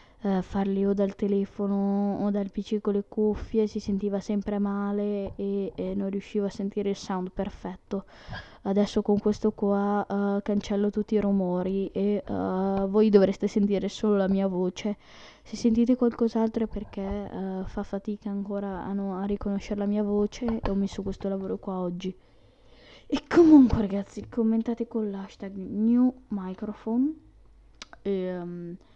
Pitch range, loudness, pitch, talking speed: 195-215 Hz, -27 LUFS, 200 Hz, 155 wpm